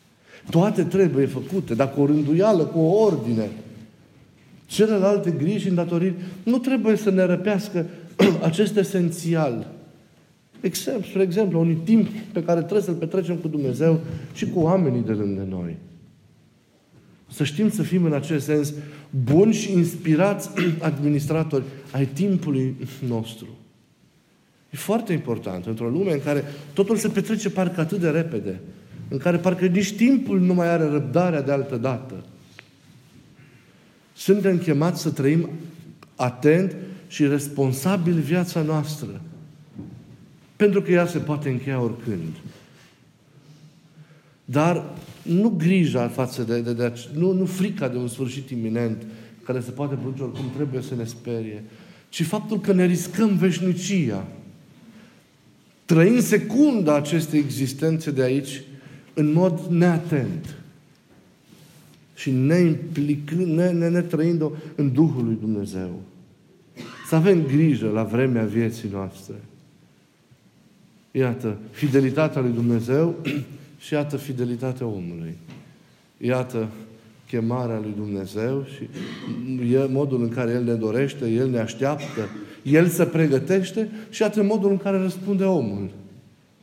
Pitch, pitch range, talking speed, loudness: 150 Hz, 130-180 Hz, 130 wpm, -22 LUFS